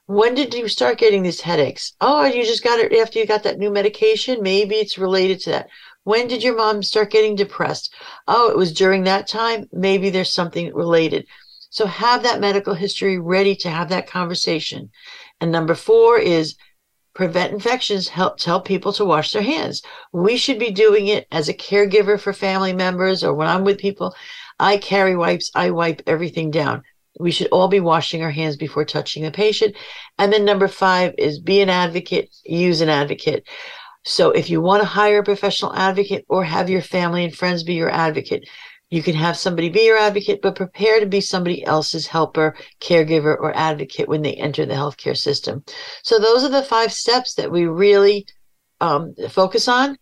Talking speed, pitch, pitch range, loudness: 195 wpm, 200 Hz, 175-225 Hz, -18 LUFS